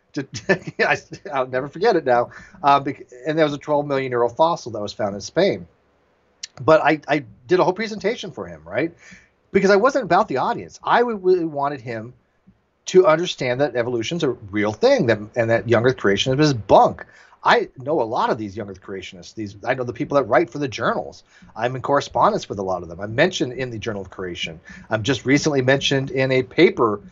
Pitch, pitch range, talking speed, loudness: 130 Hz, 110-155 Hz, 215 wpm, -20 LUFS